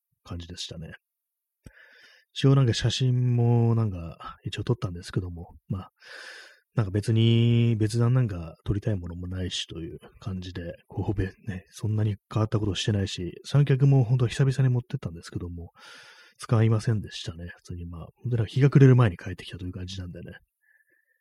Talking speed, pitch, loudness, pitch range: 375 characters per minute, 110 Hz, -26 LUFS, 90-125 Hz